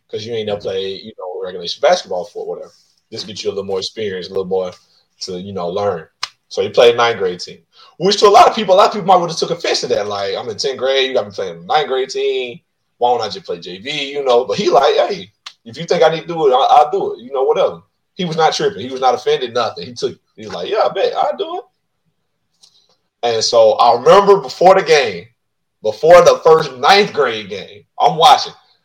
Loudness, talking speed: -14 LUFS, 250 wpm